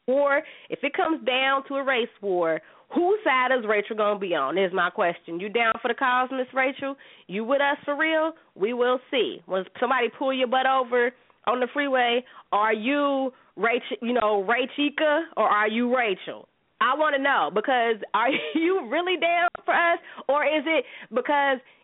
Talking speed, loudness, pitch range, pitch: 185 wpm, -24 LUFS, 230-290 Hz, 260 Hz